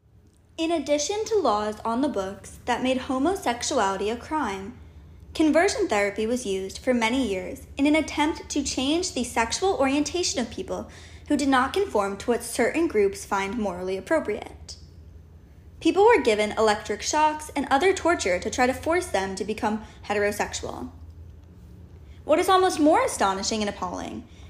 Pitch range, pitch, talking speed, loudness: 195-310 Hz, 235 Hz, 155 wpm, -24 LUFS